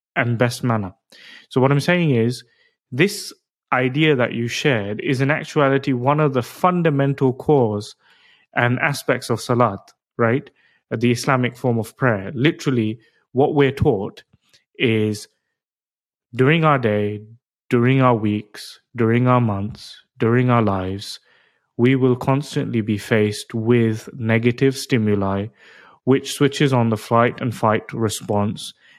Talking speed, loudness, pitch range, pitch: 130 wpm, -19 LUFS, 115-140 Hz, 125 Hz